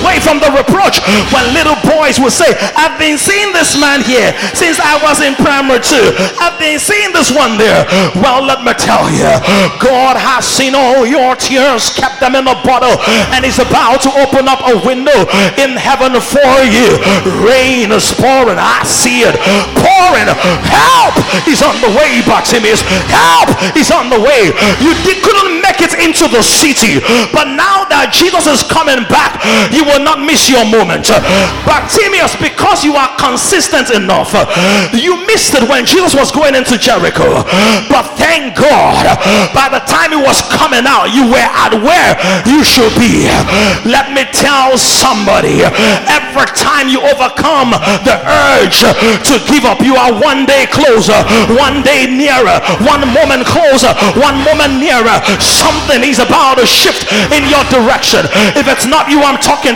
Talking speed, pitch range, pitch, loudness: 170 wpm, 255-305 Hz, 275 Hz, -7 LUFS